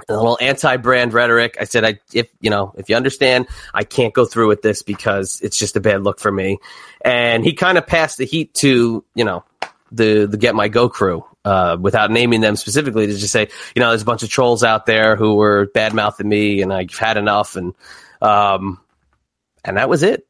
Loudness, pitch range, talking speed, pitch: -16 LUFS, 105-120 Hz, 220 wpm, 110 Hz